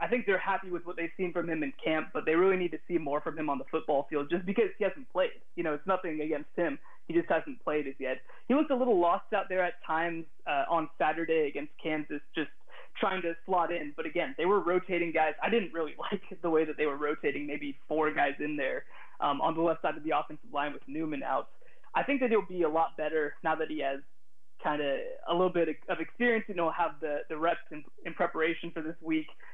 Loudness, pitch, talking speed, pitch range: -32 LUFS, 165 Hz, 255 wpm, 155-185 Hz